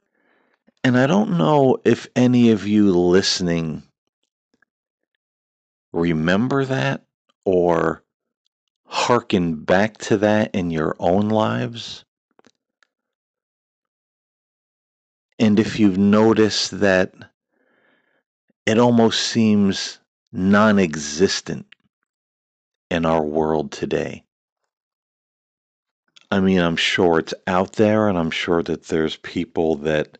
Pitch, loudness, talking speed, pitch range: 95 Hz, -19 LUFS, 95 wpm, 80-110 Hz